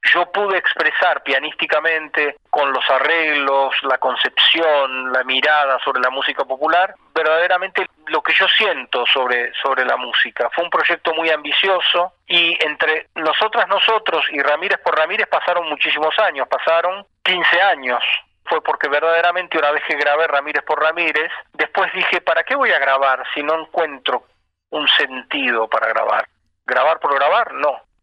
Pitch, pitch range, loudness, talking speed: 155 Hz, 145-175 Hz, -16 LUFS, 150 wpm